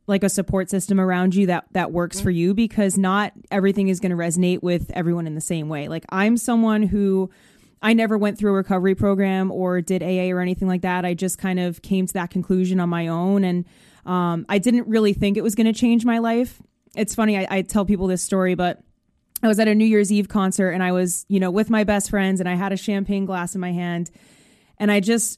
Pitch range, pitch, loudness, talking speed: 180-205 Hz, 190 Hz, -21 LUFS, 245 wpm